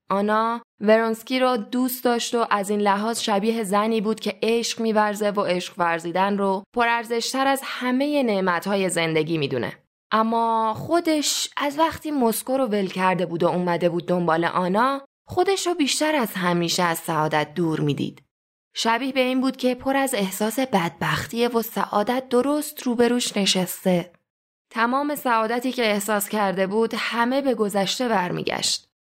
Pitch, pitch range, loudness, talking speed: 220 Hz, 185-250 Hz, -22 LUFS, 150 wpm